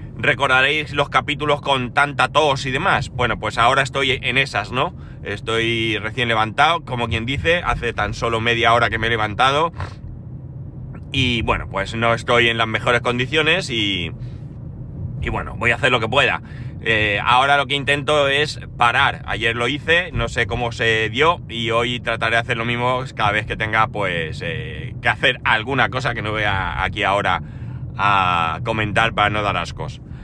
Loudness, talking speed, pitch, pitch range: -18 LUFS, 185 wpm, 120 Hz, 115-135 Hz